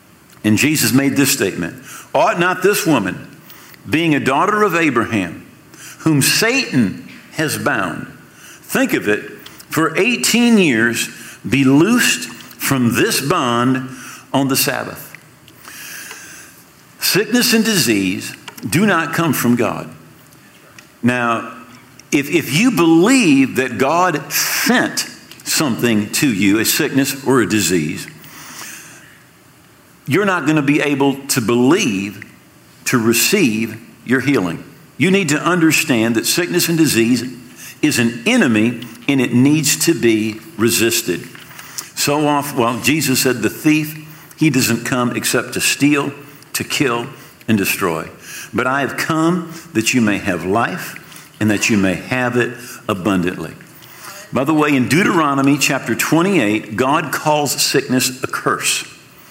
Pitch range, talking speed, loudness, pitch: 115-155 Hz, 130 wpm, -15 LUFS, 135 Hz